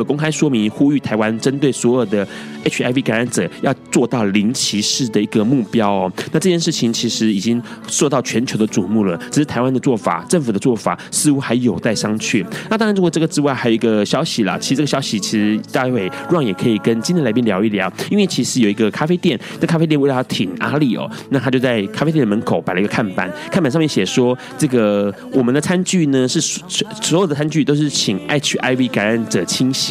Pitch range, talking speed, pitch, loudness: 110-155 Hz, 350 characters per minute, 130 Hz, -17 LUFS